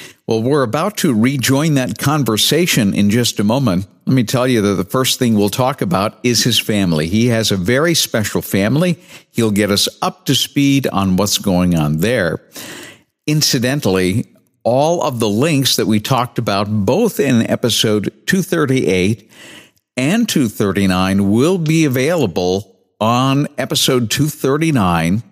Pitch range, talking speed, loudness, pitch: 100-140 Hz, 150 wpm, -15 LUFS, 120 Hz